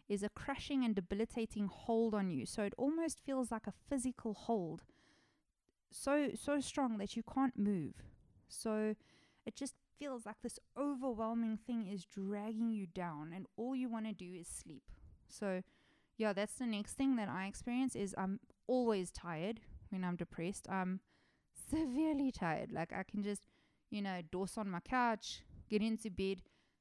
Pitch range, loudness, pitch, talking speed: 195-250 Hz, -41 LUFS, 215 Hz, 170 wpm